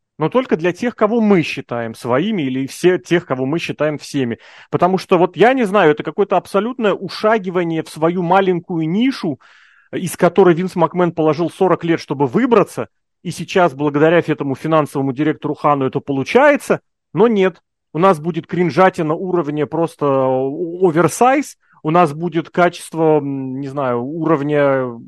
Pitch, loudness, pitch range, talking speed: 165 Hz, -16 LUFS, 145-185 Hz, 150 wpm